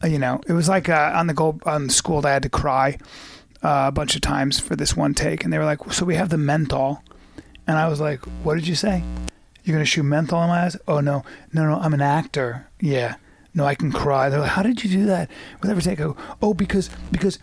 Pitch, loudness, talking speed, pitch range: 155 Hz, -21 LUFS, 255 wpm, 145-175 Hz